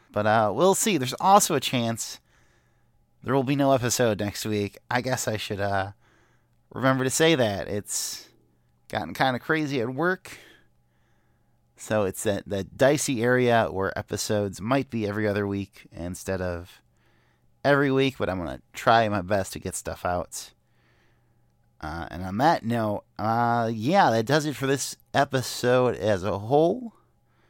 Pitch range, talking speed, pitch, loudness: 100-135 Hz, 165 wpm, 115 Hz, -25 LUFS